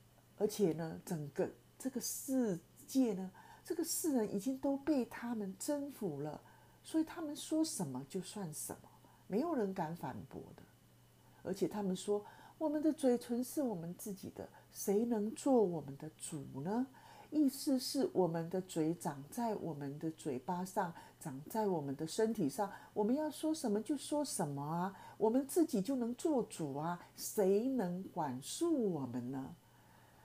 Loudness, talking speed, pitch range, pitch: -39 LUFS, 230 characters per minute, 165-265 Hz, 205 Hz